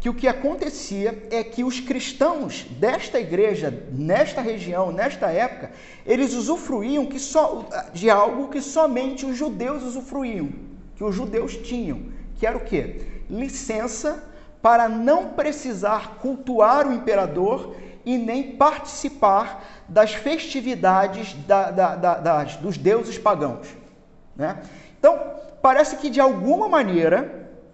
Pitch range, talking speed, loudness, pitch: 215-285 Hz, 130 wpm, -22 LUFS, 255 Hz